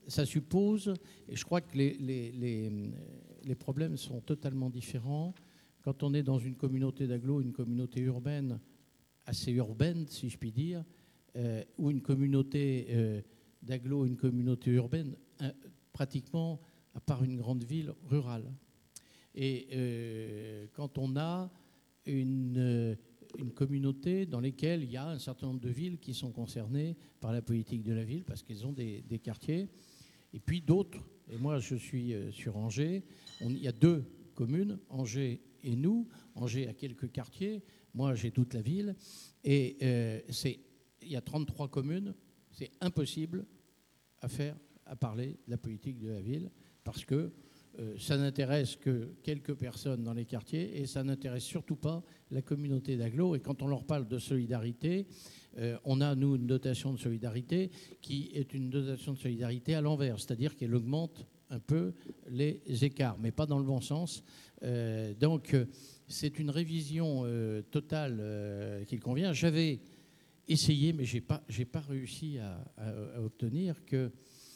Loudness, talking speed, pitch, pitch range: -36 LUFS, 160 wpm, 135 Hz, 125-150 Hz